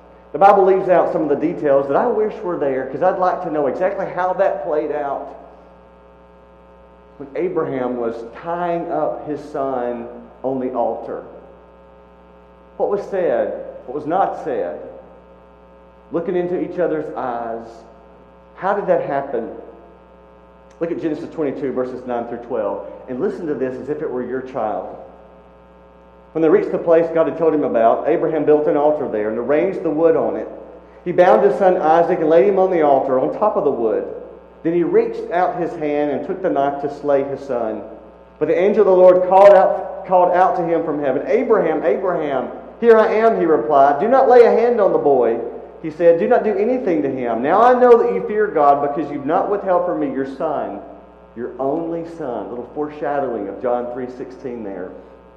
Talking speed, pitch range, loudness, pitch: 195 wpm, 115-180 Hz, -17 LUFS, 145 Hz